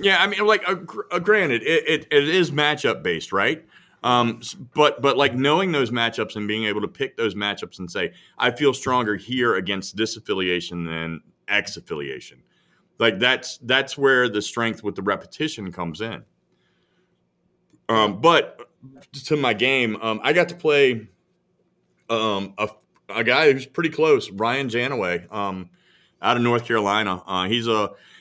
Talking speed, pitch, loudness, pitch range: 165 wpm, 120 Hz, -21 LUFS, 105-140 Hz